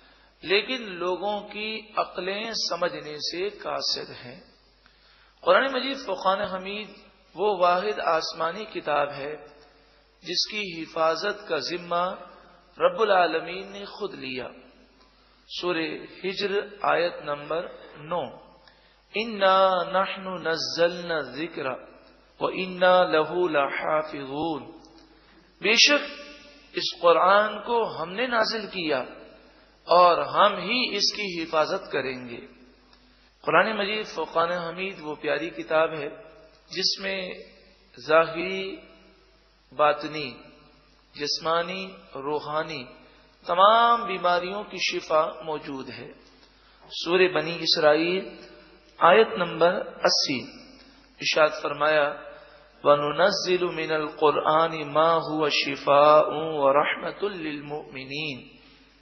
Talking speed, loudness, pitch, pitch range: 80 wpm, -24 LUFS, 175 Hz, 155-195 Hz